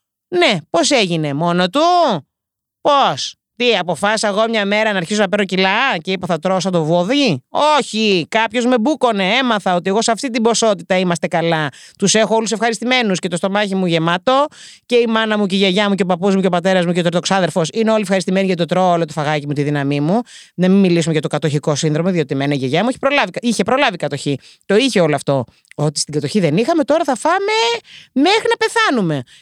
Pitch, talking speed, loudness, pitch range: 195 Hz, 220 wpm, -16 LUFS, 170-235 Hz